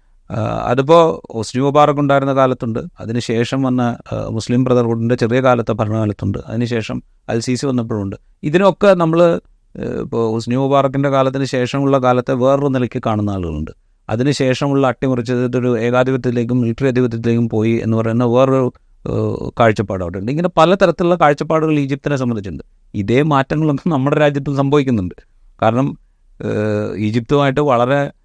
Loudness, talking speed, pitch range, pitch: -16 LUFS, 110 wpm, 115-140 Hz, 125 Hz